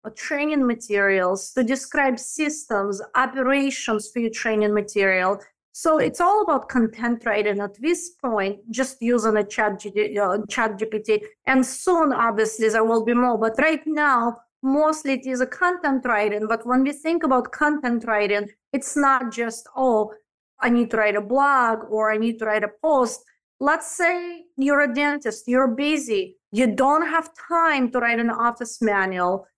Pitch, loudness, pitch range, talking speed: 245 Hz, -22 LUFS, 215-285 Hz, 170 wpm